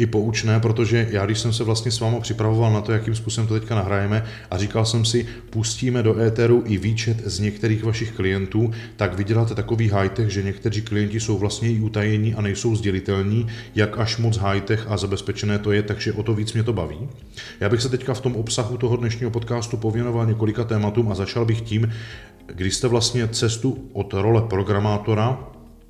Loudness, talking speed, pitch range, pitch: -22 LUFS, 195 wpm, 105-115 Hz, 110 Hz